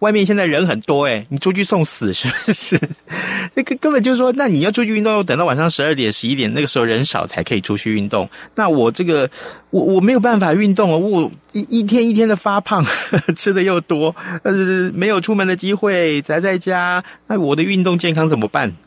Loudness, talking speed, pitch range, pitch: -16 LUFS, 320 characters per minute, 155-210 Hz, 185 Hz